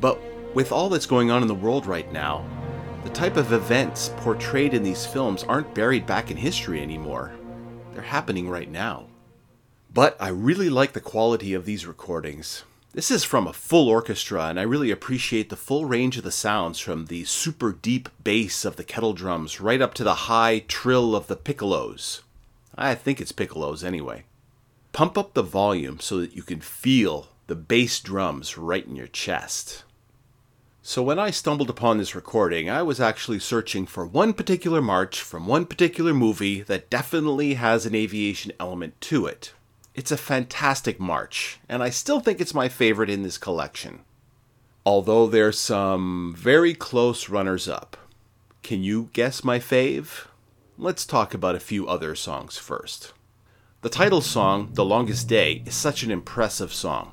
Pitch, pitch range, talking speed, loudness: 115 Hz, 95-130 Hz, 175 wpm, -24 LUFS